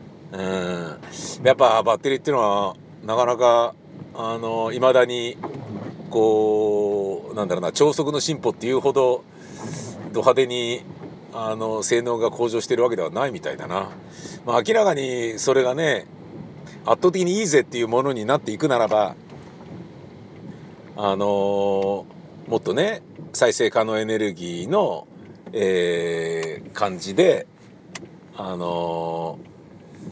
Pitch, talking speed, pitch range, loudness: 115 Hz, 245 characters per minute, 100-135 Hz, -22 LUFS